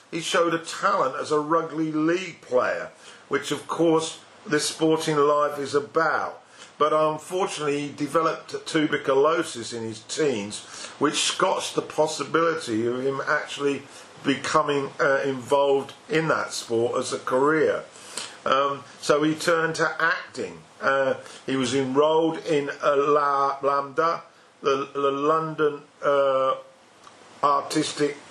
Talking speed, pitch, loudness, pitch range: 130 wpm, 145 Hz, -24 LUFS, 140-160 Hz